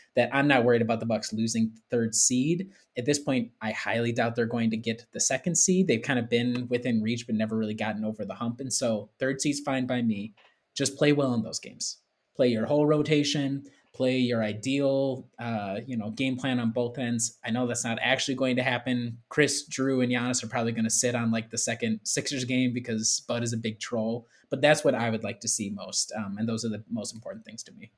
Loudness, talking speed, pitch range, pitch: -27 LUFS, 240 wpm, 115-135 Hz, 120 Hz